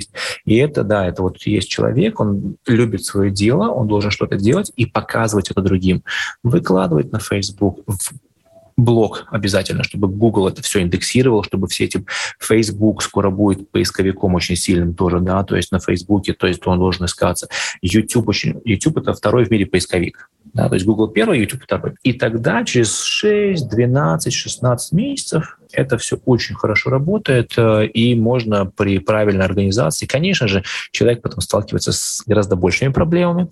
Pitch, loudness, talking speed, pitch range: 105 Hz, -17 LUFS, 165 wpm, 95-120 Hz